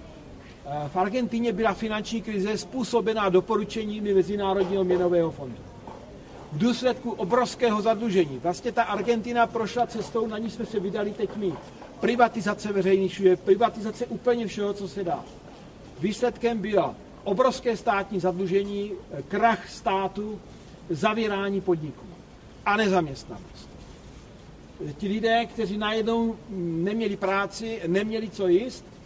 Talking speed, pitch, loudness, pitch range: 110 wpm, 205 Hz, -26 LUFS, 190-225 Hz